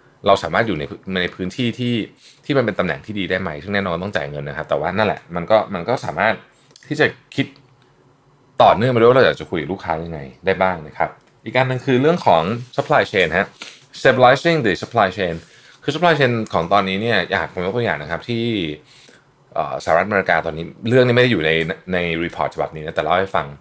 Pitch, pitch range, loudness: 105 Hz, 85-125 Hz, -19 LUFS